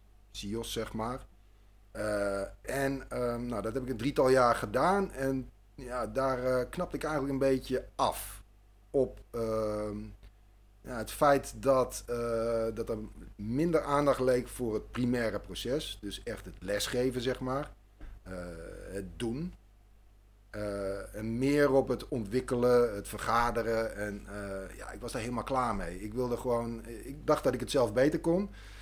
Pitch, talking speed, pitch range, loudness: 115 Hz, 160 wpm, 105-130 Hz, -32 LUFS